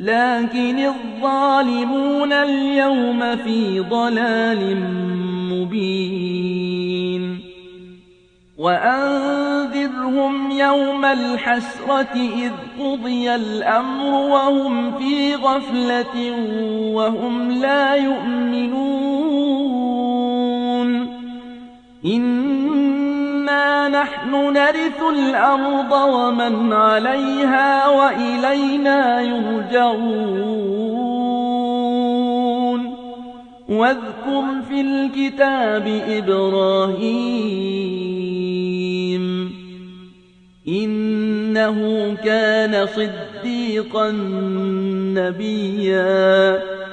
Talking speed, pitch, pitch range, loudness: 45 wpm, 245 Hz, 205-275 Hz, -19 LUFS